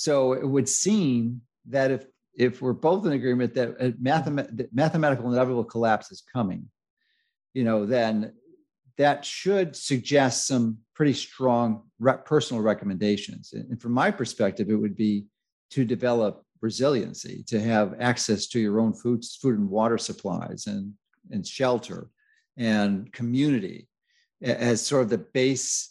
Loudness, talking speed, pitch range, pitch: -25 LUFS, 145 wpm, 115-140 Hz, 125 Hz